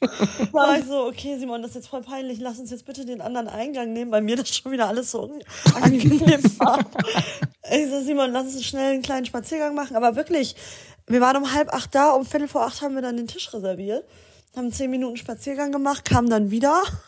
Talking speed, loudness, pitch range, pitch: 215 wpm, -22 LUFS, 235-280 Hz, 260 Hz